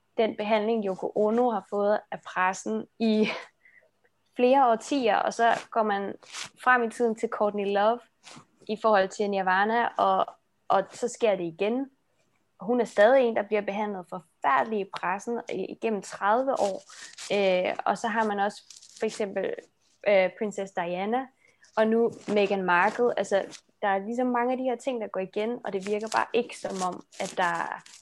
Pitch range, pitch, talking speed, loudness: 195-235 Hz, 215 Hz, 175 wpm, -27 LUFS